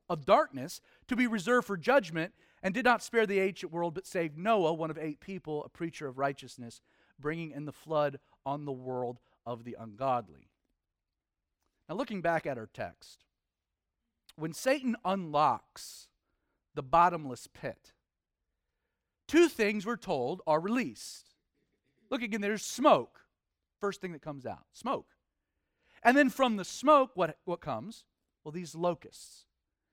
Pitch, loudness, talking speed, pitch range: 170 Hz, -31 LUFS, 150 wpm, 150-225 Hz